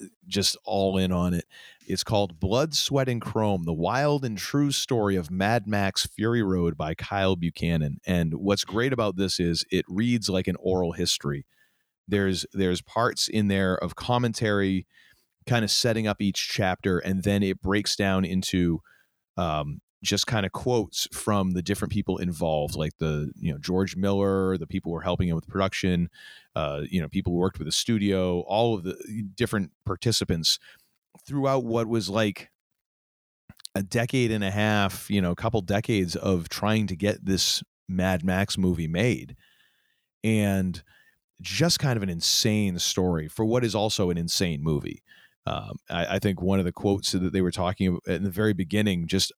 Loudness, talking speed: -26 LUFS, 180 wpm